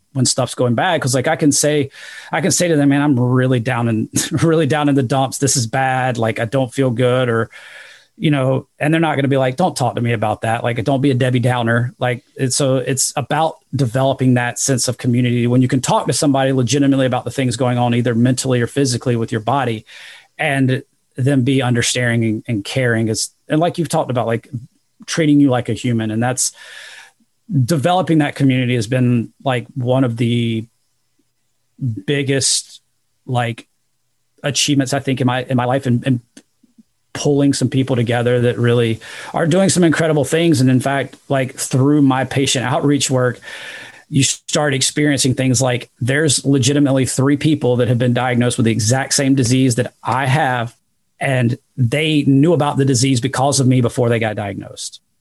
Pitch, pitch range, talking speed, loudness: 130 Hz, 125-140 Hz, 195 wpm, -16 LUFS